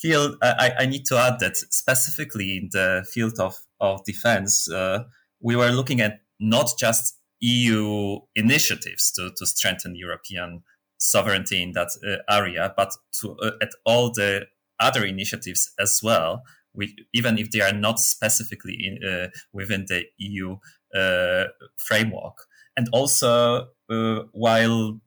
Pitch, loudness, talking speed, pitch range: 110 Hz, -22 LUFS, 145 wpm, 95-120 Hz